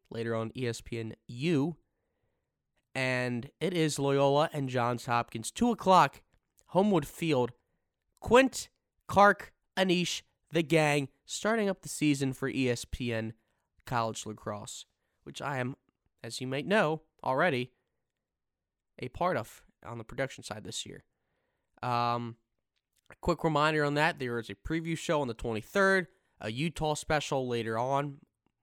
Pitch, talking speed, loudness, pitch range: 135 Hz, 135 wpm, -30 LUFS, 115-160 Hz